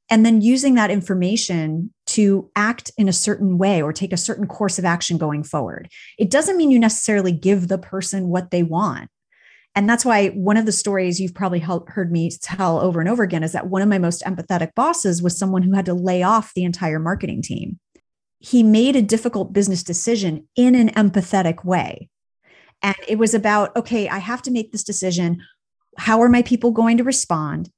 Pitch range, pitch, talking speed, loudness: 180-225 Hz, 195 Hz, 205 wpm, -19 LUFS